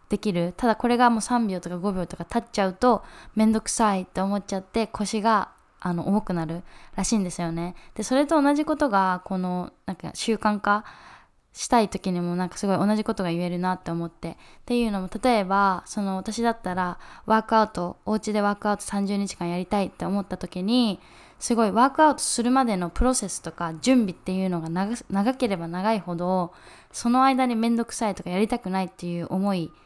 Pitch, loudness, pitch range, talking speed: 200 Hz, -25 LUFS, 185-225 Hz, 405 characters per minute